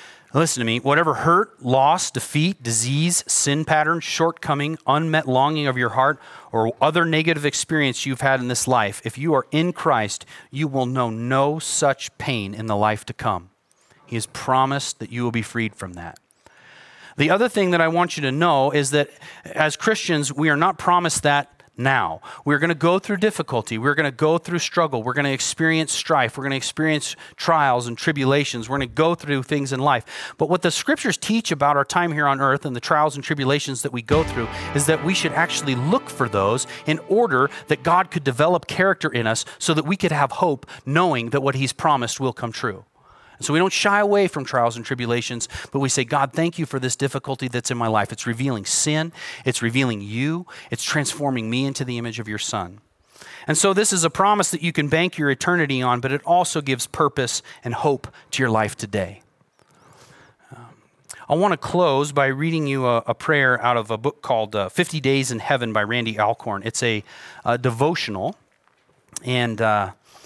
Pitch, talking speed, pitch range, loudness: 140 Hz, 210 wpm, 120-160 Hz, -21 LUFS